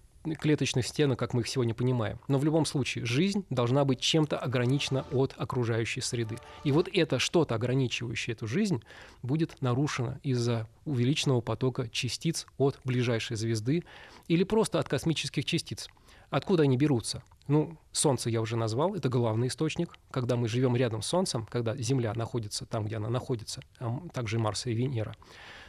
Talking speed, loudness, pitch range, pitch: 160 wpm, -30 LUFS, 120-150 Hz, 130 Hz